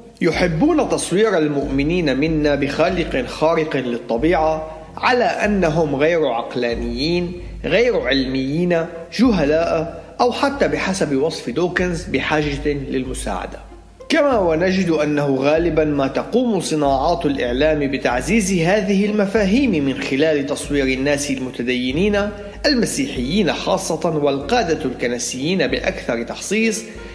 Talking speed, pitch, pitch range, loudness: 95 wpm, 160 Hz, 140-190 Hz, -18 LUFS